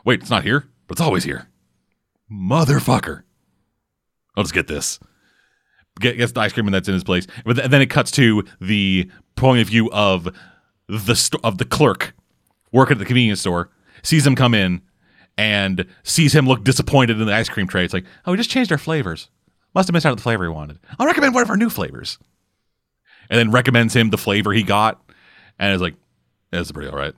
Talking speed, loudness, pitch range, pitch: 215 wpm, -18 LUFS, 95-130 Hz, 110 Hz